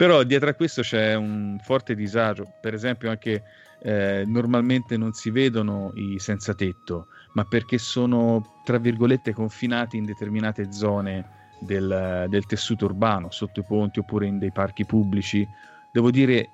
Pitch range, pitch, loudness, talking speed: 100-120 Hz, 105 Hz, -24 LUFS, 150 wpm